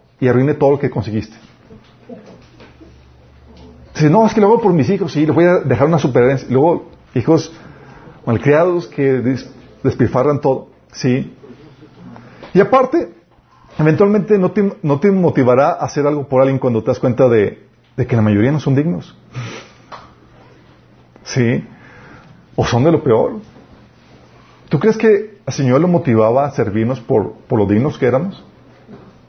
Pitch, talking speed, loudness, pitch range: 135 Hz, 155 wpm, -15 LUFS, 125-165 Hz